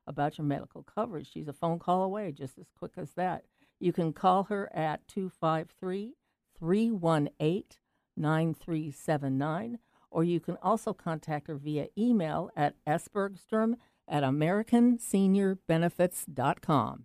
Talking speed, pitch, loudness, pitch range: 115 wpm, 170 Hz, -31 LUFS, 155-200 Hz